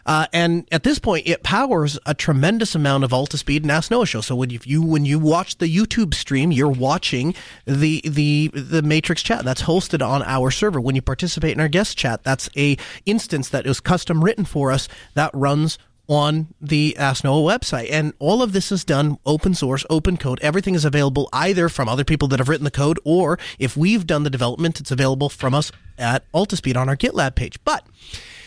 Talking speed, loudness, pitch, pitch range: 205 wpm, -19 LUFS, 150 Hz, 135-170 Hz